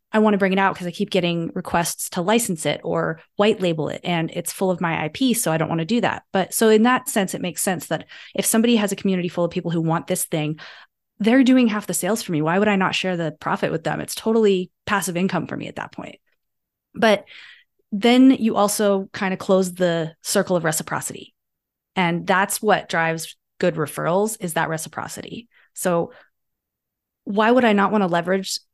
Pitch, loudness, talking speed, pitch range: 190 Hz, -21 LUFS, 220 wpm, 170-210 Hz